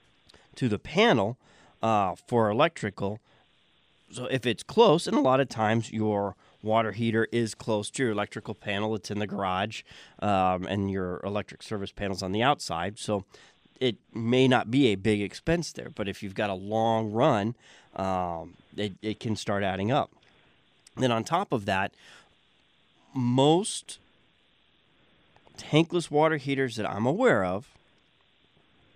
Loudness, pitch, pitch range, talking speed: -27 LUFS, 110 Hz, 100-125 Hz, 150 wpm